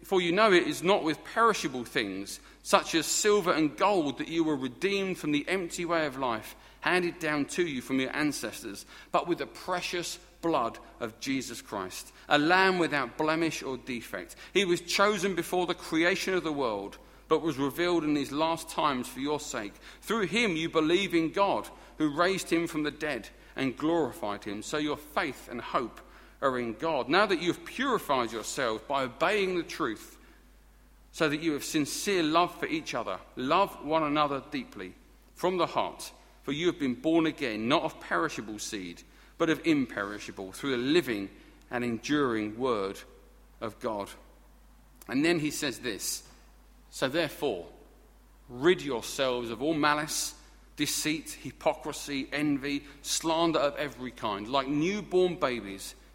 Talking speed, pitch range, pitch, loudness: 165 wpm, 140-180 Hz, 160 Hz, -29 LUFS